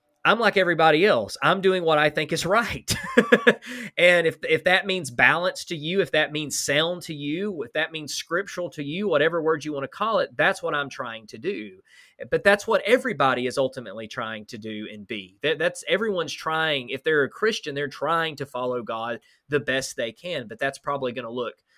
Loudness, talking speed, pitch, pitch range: -23 LUFS, 215 wpm, 160 Hz, 135-185 Hz